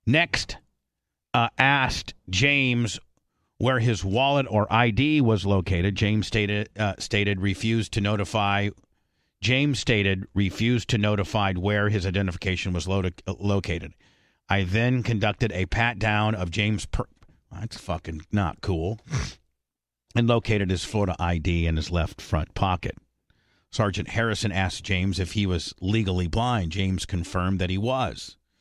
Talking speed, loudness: 140 wpm, -25 LUFS